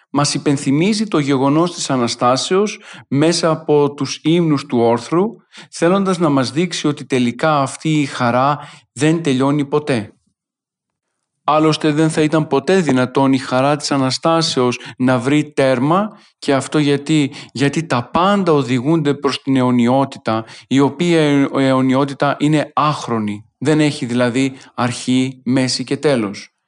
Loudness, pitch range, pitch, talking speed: -16 LUFS, 130-155 Hz, 140 Hz, 135 wpm